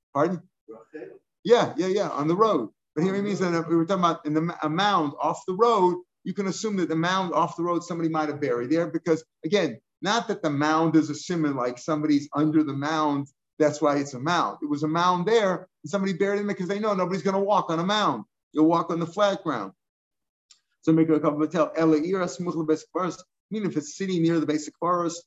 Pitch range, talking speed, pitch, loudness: 155-185 Hz, 235 wpm, 165 Hz, -25 LUFS